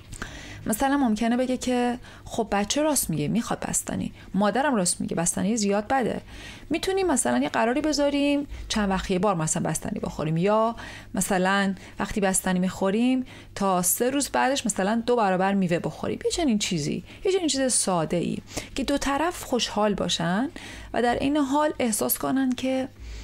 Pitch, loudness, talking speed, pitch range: 230 Hz, -25 LUFS, 160 wpm, 195-270 Hz